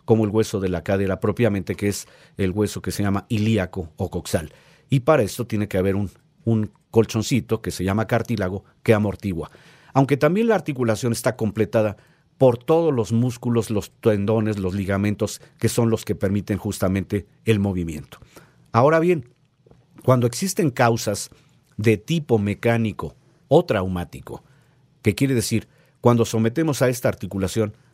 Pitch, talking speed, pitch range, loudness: 110 Hz, 155 wpm, 100-130 Hz, -22 LUFS